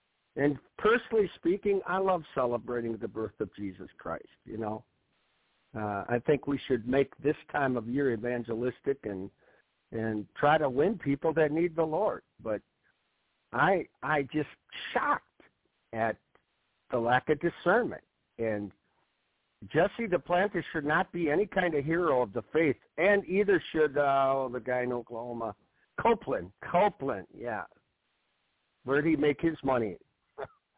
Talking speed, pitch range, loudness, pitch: 145 wpm, 120-165 Hz, -30 LUFS, 140 Hz